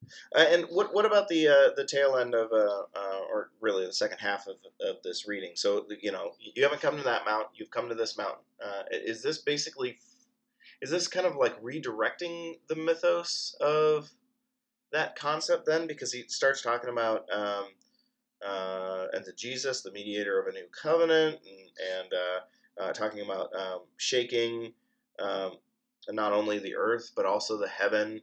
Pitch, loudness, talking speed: 155 Hz, -30 LUFS, 185 wpm